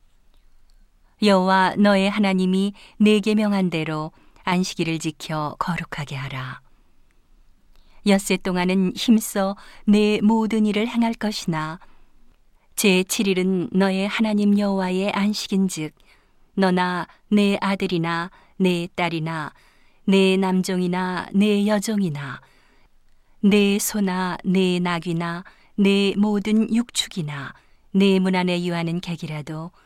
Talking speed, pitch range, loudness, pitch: 215 characters per minute, 170-205 Hz, -21 LUFS, 185 Hz